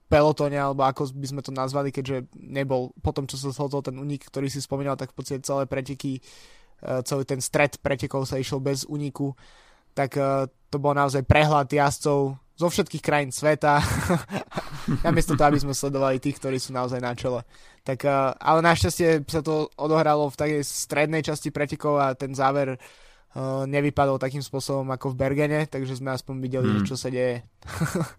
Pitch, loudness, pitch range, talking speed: 140 Hz, -25 LUFS, 135-145 Hz, 170 wpm